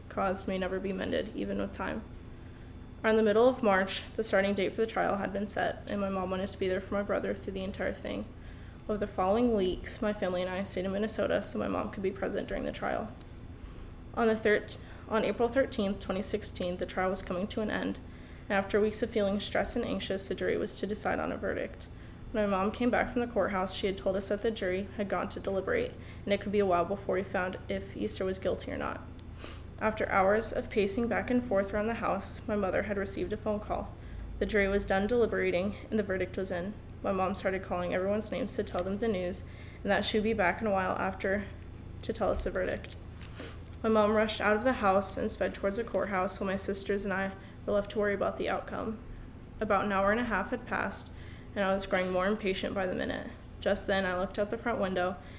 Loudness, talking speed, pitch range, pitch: -31 LUFS, 240 wpm, 185-210 Hz, 195 Hz